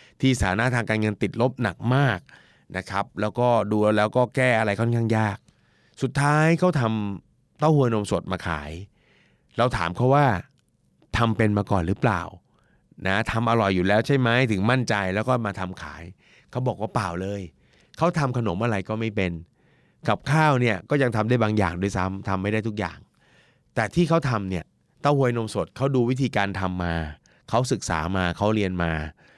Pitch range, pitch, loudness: 95-125 Hz, 110 Hz, -24 LUFS